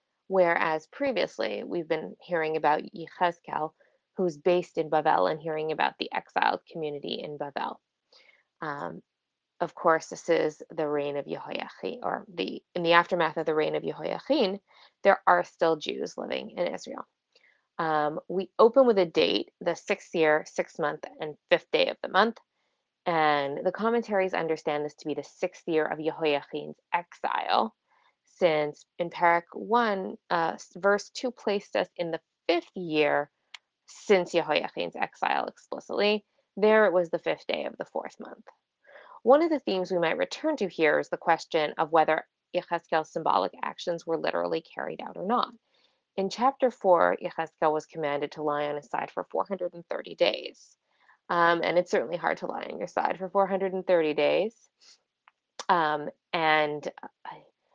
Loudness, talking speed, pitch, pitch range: -28 LUFS, 160 wpm, 170 Hz, 155-190 Hz